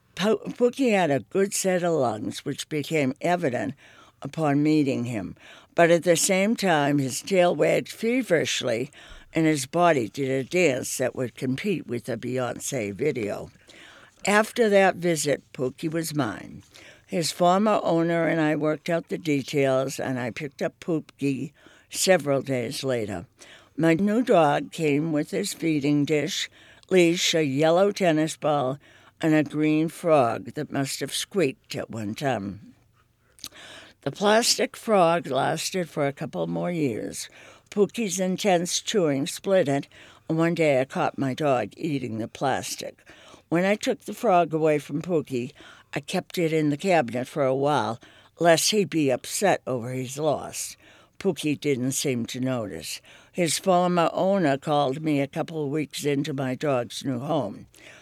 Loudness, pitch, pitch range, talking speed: -24 LUFS, 155 Hz, 135-175 Hz, 155 wpm